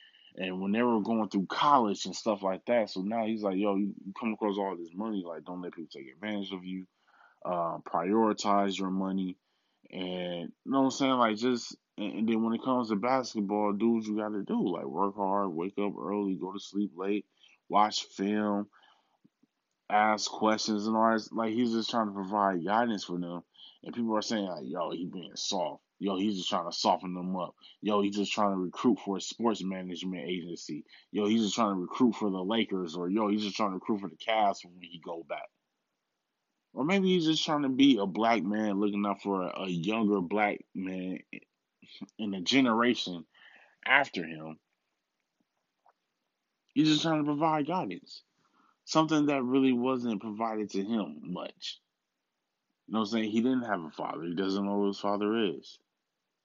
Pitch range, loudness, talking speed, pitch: 95-115 Hz, -30 LUFS, 200 wpm, 105 Hz